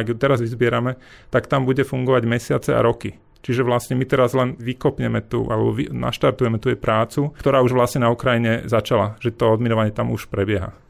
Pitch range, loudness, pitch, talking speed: 115-130 Hz, -20 LUFS, 120 Hz, 195 wpm